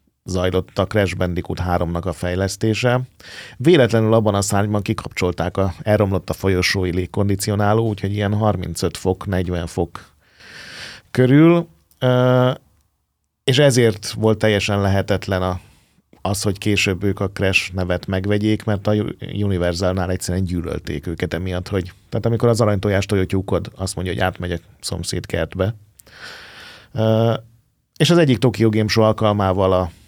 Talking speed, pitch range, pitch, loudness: 130 wpm, 90-110 Hz, 100 Hz, -19 LUFS